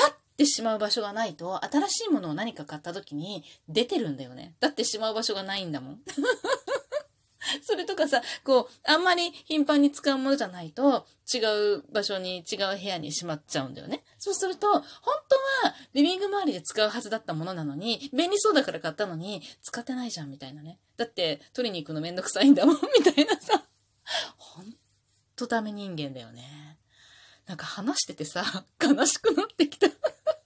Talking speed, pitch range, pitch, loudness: 375 characters per minute, 180-300 Hz, 230 Hz, -27 LUFS